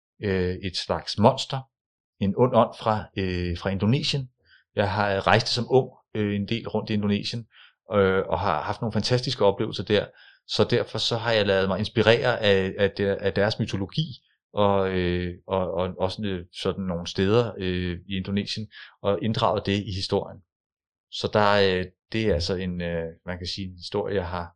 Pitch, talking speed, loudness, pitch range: 100 Hz, 180 wpm, -25 LUFS, 95-110 Hz